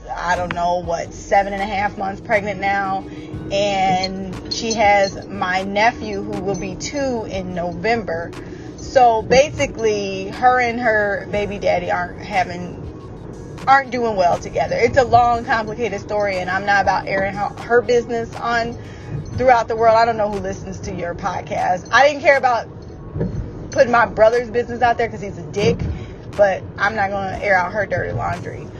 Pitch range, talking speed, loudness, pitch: 190-235 Hz, 175 wpm, -18 LUFS, 205 Hz